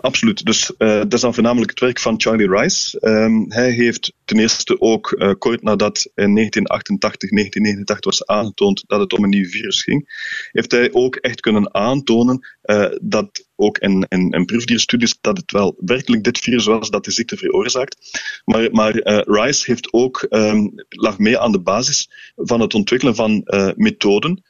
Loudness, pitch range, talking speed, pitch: -16 LUFS, 105-125 Hz, 185 wpm, 110 Hz